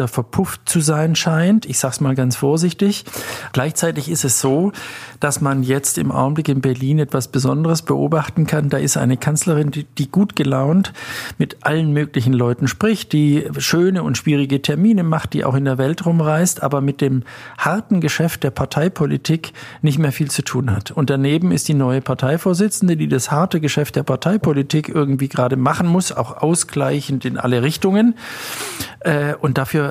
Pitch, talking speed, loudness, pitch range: 150 Hz, 175 wpm, -18 LUFS, 135-165 Hz